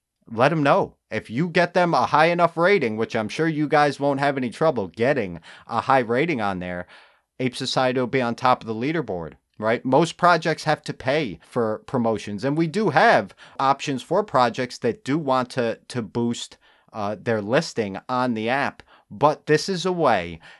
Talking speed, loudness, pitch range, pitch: 195 wpm, -22 LUFS, 115-155 Hz, 130 Hz